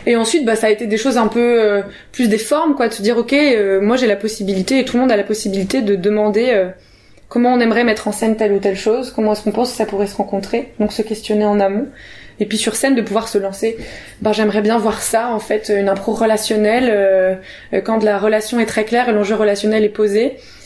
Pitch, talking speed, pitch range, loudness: 220 Hz, 260 wpm, 205-235 Hz, -16 LUFS